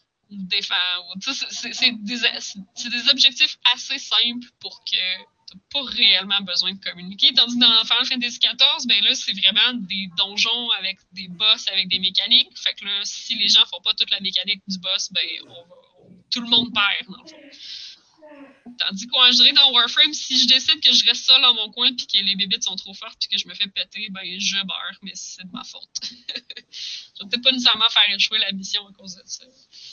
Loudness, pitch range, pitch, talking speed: -17 LUFS, 195-255 Hz, 225 Hz, 220 wpm